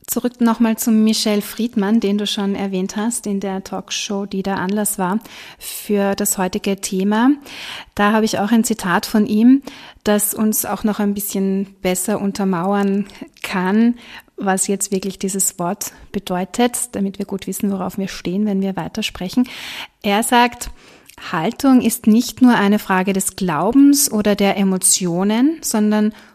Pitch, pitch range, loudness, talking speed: 205 Hz, 195-225 Hz, -17 LUFS, 155 wpm